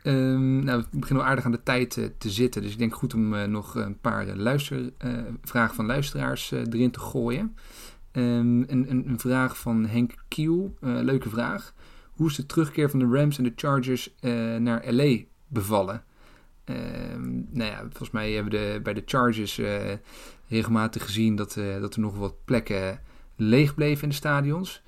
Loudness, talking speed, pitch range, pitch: -26 LUFS, 195 wpm, 110-130 Hz, 120 Hz